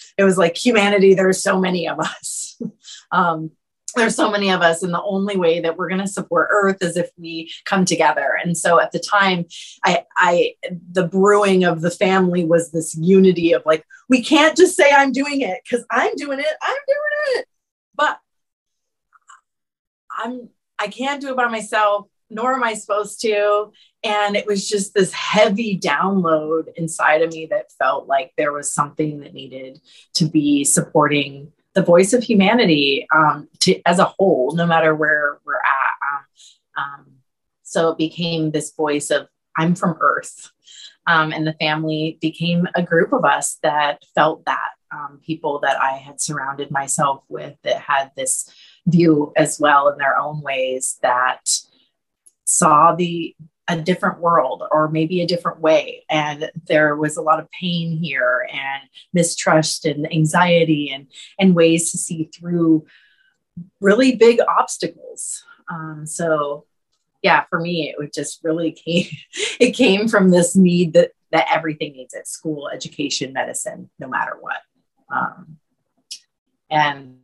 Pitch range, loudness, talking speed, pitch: 155-200 Hz, -18 LUFS, 160 wpm, 170 Hz